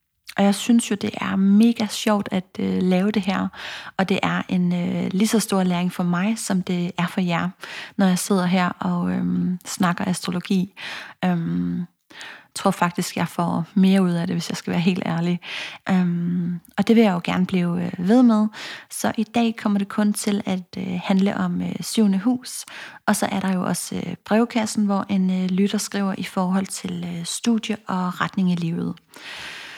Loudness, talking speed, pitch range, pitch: -22 LUFS, 200 wpm, 180-210 Hz, 190 Hz